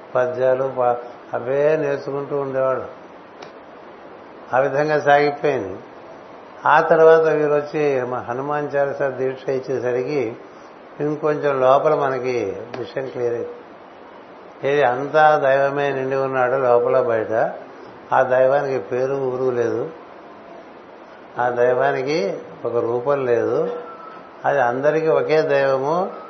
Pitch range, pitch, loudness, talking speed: 125-145 Hz, 135 Hz, -19 LUFS, 100 wpm